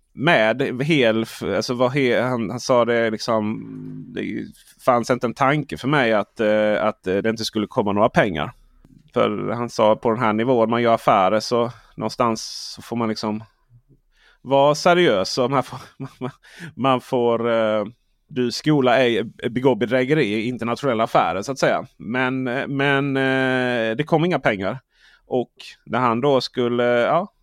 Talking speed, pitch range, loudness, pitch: 155 wpm, 115-130 Hz, -20 LUFS, 120 Hz